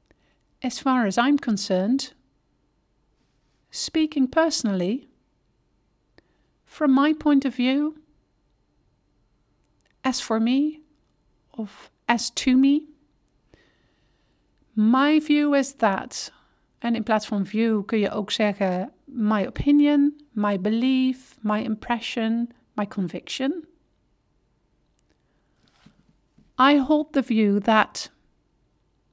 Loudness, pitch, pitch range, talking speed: -23 LUFS, 255 Hz, 215-285 Hz, 90 wpm